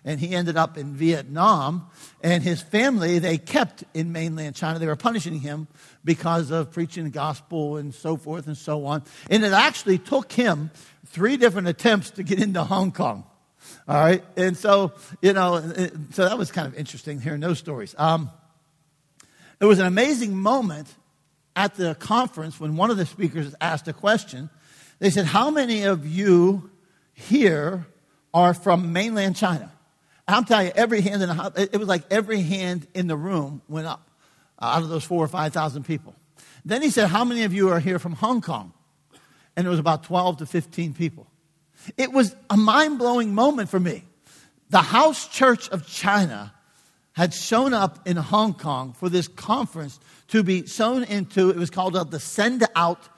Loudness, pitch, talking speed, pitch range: -22 LUFS, 175 Hz, 185 wpm, 155-200 Hz